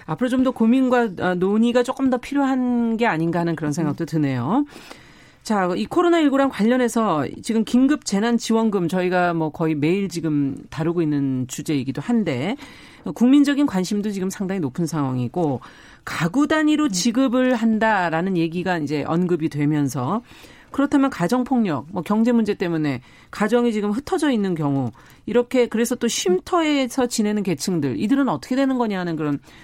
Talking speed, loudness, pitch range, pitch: 345 characters per minute, -21 LUFS, 165-250 Hz, 210 Hz